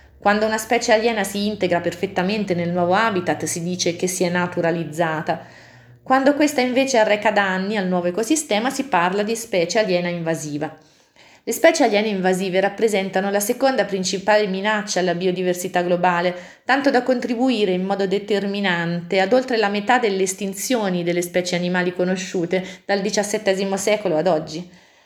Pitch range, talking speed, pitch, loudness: 180-215 Hz, 155 wpm, 195 Hz, -20 LUFS